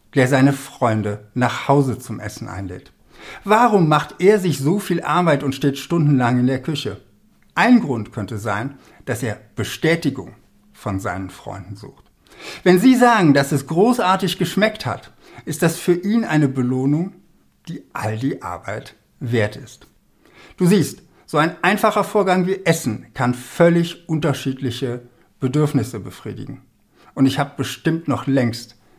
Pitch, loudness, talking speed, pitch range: 140 Hz, -19 LUFS, 145 wpm, 120-170 Hz